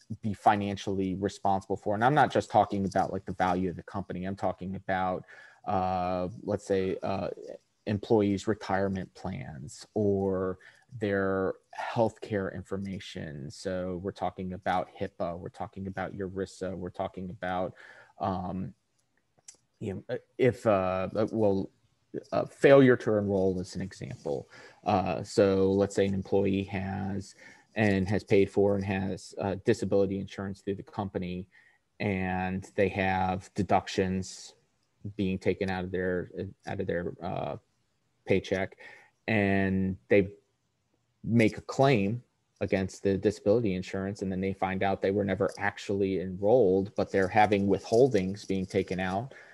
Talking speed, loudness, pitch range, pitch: 140 wpm, -29 LUFS, 95-100 Hz, 95 Hz